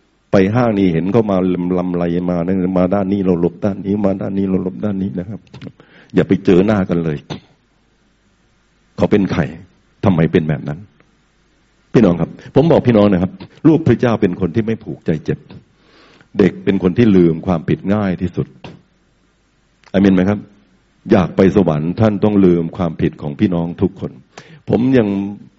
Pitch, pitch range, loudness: 95 Hz, 90-105 Hz, -15 LUFS